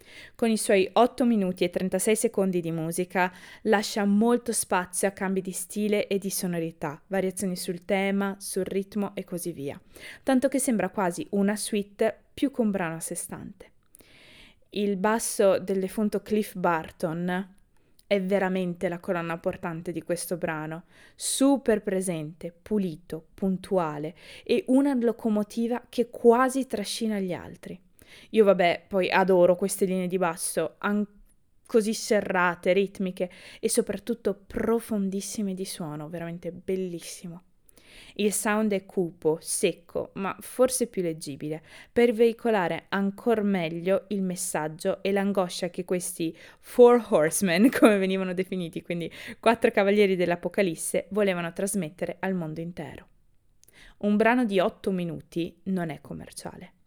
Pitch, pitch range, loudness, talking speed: 190 Hz, 175-210 Hz, -26 LUFS, 135 wpm